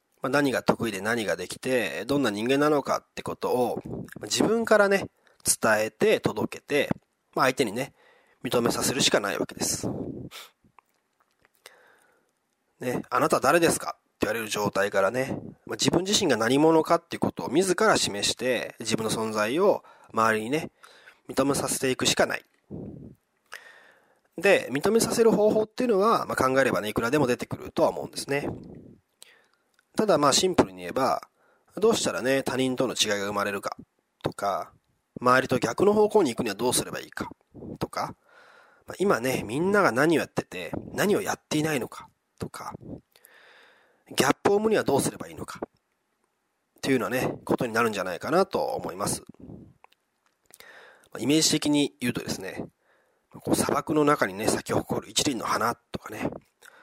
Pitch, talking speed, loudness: 145 Hz, 315 characters per minute, -25 LUFS